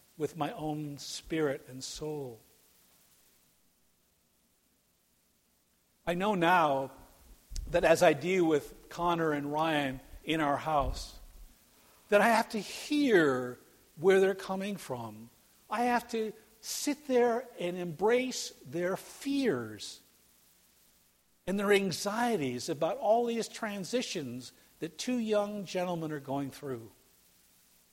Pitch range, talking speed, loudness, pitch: 130-205 Hz, 110 wpm, -31 LUFS, 165 Hz